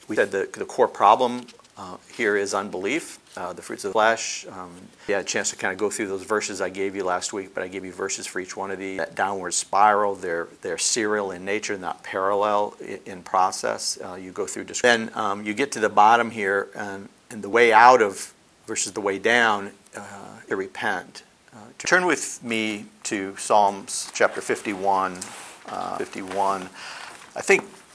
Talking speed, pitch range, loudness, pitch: 200 wpm, 95-105 Hz, -23 LUFS, 100 Hz